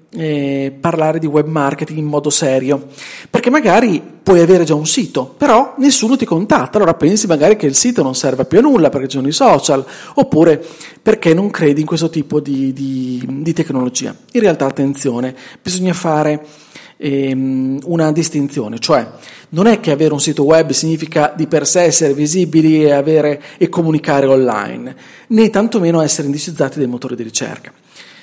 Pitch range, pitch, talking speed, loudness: 140-165 Hz, 155 Hz, 170 wpm, -13 LUFS